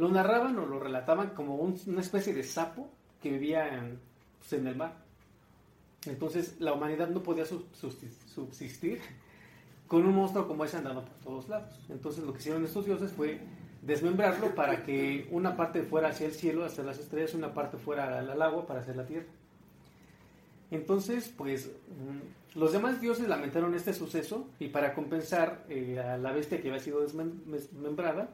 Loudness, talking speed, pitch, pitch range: -33 LUFS, 170 wpm, 160 Hz, 140-175 Hz